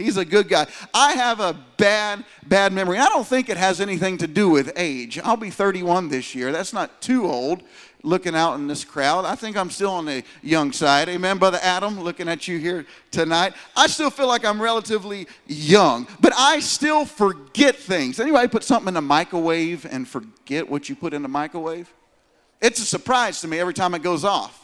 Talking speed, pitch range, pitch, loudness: 210 wpm, 165-225 Hz, 185 Hz, -20 LUFS